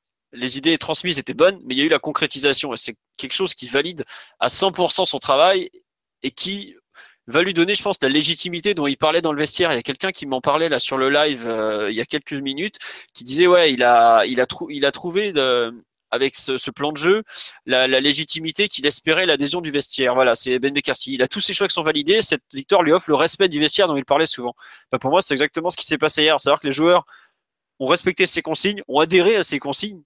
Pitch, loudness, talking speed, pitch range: 150 Hz, -18 LUFS, 255 wpm, 135-180 Hz